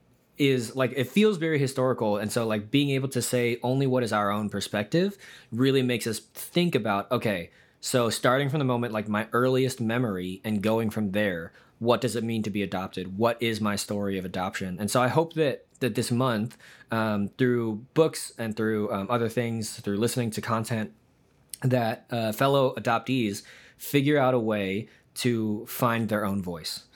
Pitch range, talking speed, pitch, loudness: 105-130 Hz, 185 wpm, 115 Hz, -27 LUFS